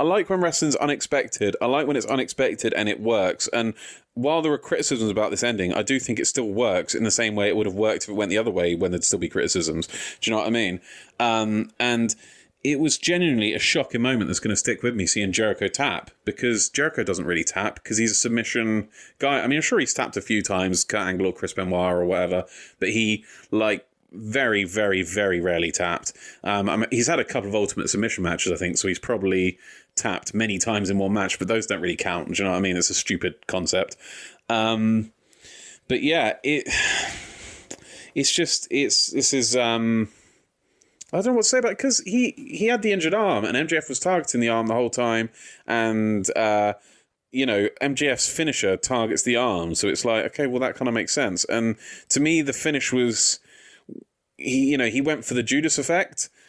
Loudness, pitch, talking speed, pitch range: -23 LUFS, 115 Hz, 215 wpm, 105-140 Hz